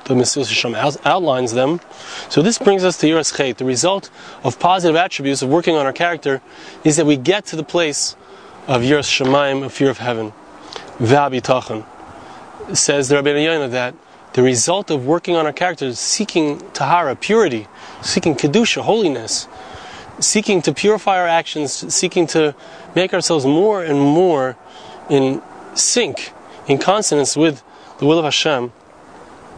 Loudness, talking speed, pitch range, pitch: -16 LUFS, 155 wpm, 135-175 Hz, 150 Hz